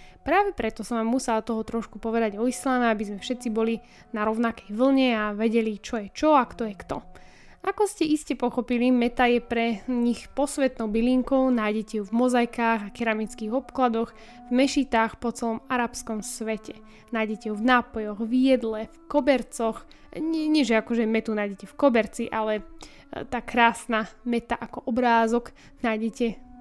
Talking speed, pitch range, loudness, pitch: 160 wpm, 220-250 Hz, -25 LUFS, 235 Hz